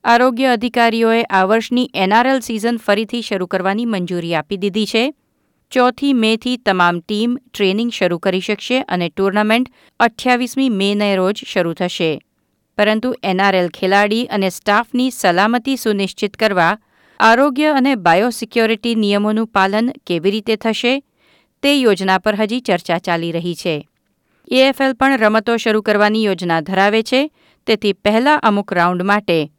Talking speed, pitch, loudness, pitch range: 130 wpm, 215 Hz, -16 LUFS, 190-240 Hz